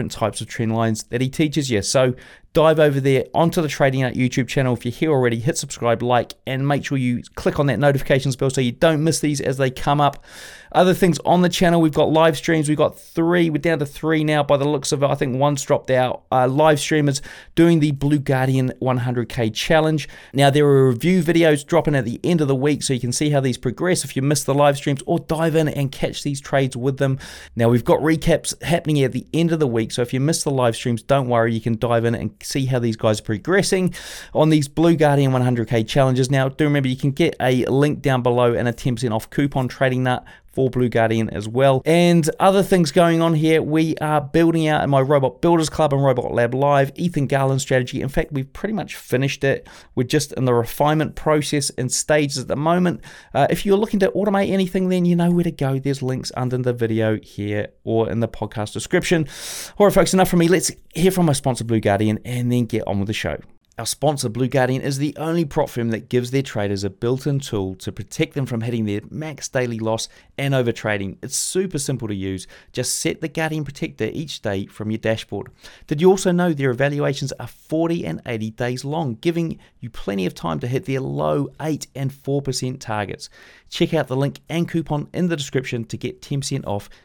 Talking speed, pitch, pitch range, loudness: 235 wpm, 140 Hz, 120-155 Hz, -20 LUFS